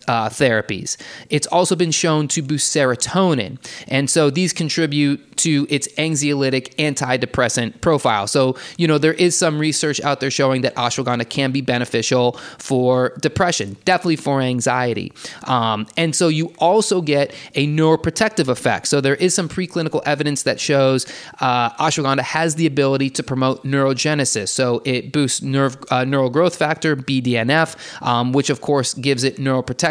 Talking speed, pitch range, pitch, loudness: 160 wpm, 130-160 Hz, 140 Hz, -18 LUFS